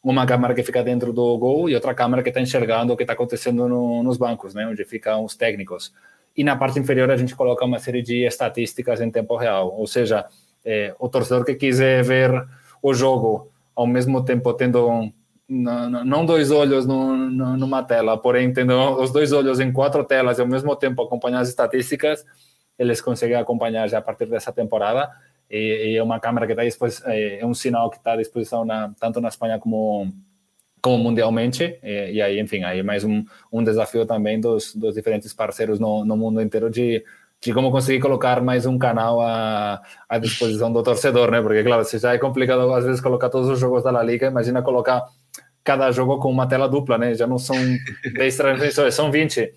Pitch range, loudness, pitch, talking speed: 115-130 Hz, -20 LUFS, 125 Hz, 205 wpm